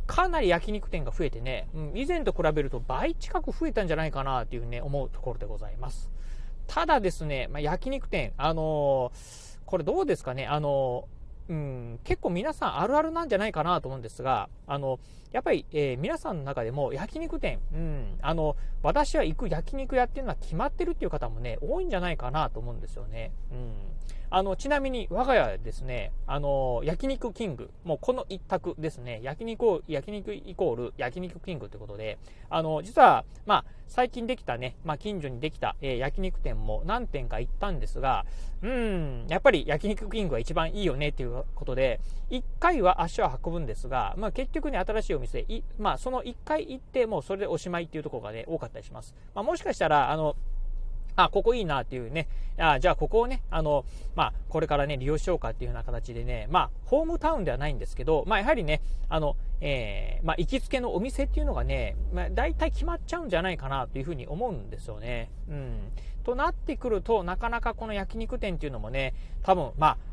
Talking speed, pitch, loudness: 415 characters per minute, 155 Hz, -30 LUFS